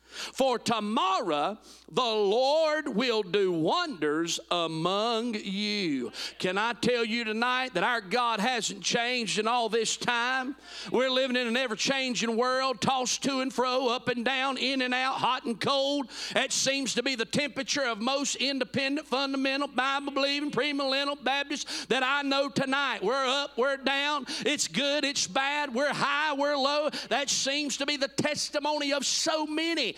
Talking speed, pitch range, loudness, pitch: 160 wpm, 235-280 Hz, -28 LUFS, 265 Hz